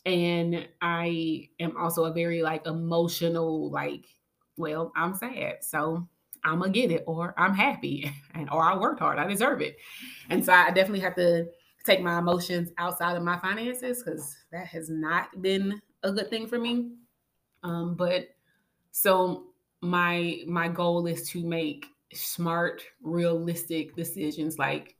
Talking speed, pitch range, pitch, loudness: 155 wpm, 165-185 Hz, 170 Hz, -28 LUFS